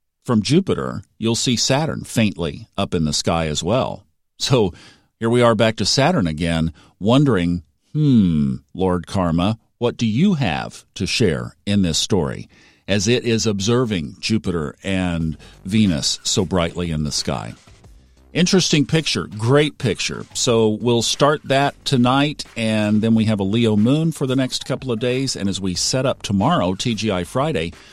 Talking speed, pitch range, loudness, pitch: 160 wpm, 90-125 Hz, -19 LUFS, 110 Hz